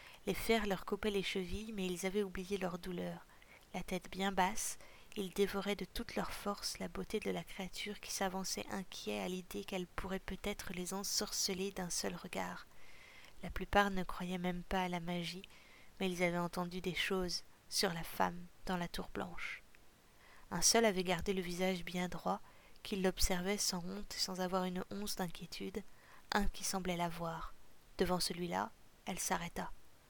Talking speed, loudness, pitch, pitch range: 175 wpm, -39 LUFS, 190 Hz, 180-200 Hz